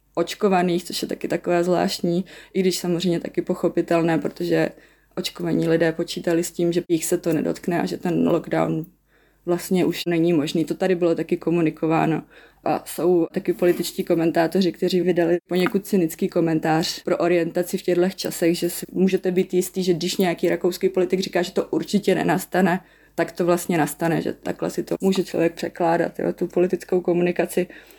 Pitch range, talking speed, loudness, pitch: 170-180 Hz, 170 wpm, -22 LUFS, 175 Hz